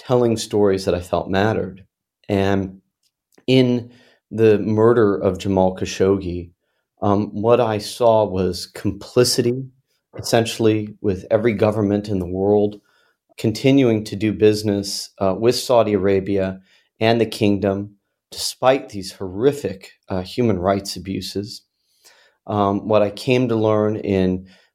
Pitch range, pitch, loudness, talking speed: 95-110 Hz, 105 Hz, -19 LUFS, 125 wpm